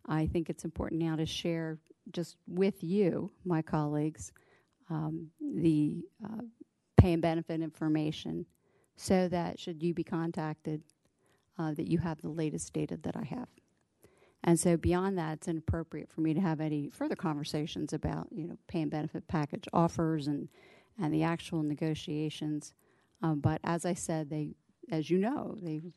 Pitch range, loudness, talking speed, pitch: 155-175 Hz, -34 LUFS, 165 wpm, 165 Hz